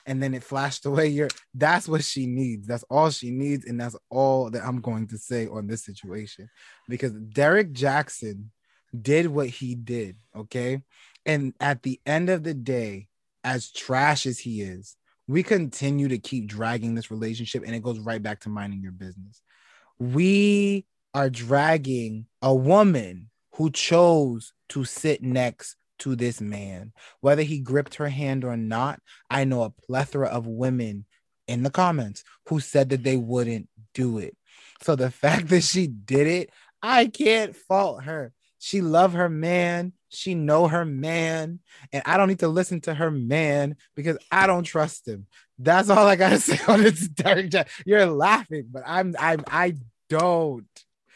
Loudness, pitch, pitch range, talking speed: -24 LUFS, 135 Hz, 120-165 Hz, 170 wpm